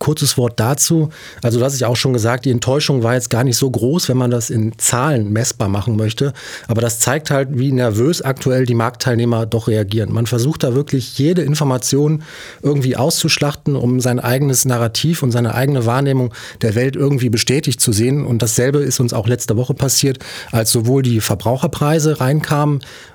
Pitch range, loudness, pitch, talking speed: 120-140 Hz, -16 LUFS, 125 Hz, 190 wpm